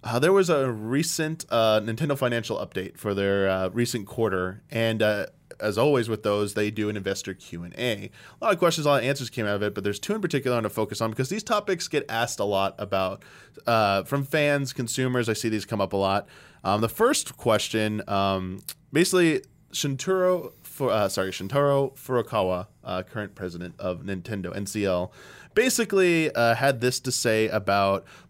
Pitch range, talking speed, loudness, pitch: 100-140 Hz, 195 wpm, -25 LUFS, 110 Hz